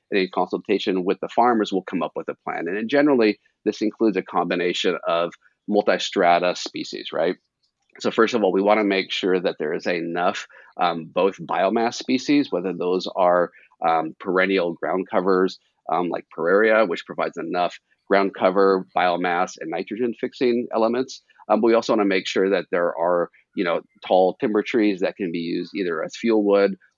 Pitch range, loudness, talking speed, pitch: 95-110 Hz, -22 LUFS, 180 wpm, 100 Hz